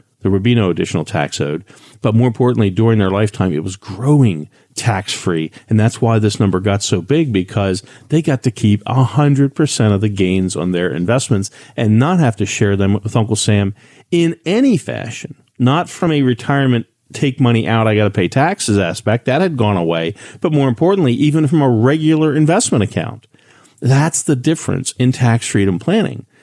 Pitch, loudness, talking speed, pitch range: 115 Hz, -15 LUFS, 195 wpm, 105-140 Hz